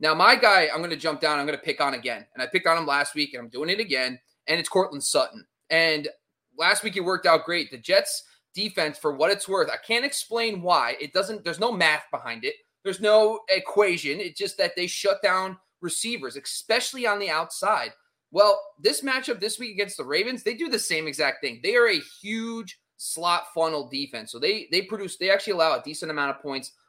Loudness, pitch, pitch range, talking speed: -24 LUFS, 190 Hz, 155-225 Hz, 225 wpm